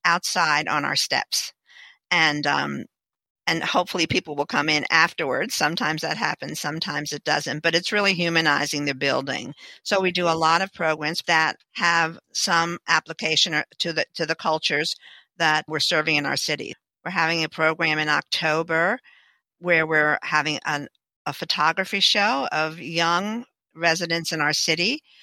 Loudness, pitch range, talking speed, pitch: -22 LUFS, 155-175 Hz, 155 wpm, 165 Hz